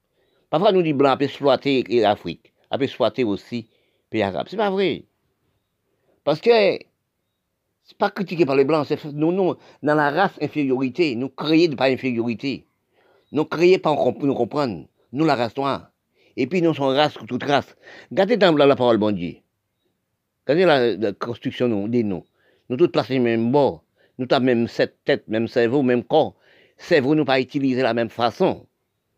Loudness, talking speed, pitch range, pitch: -20 LUFS, 185 wpm, 120-155 Hz, 140 Hz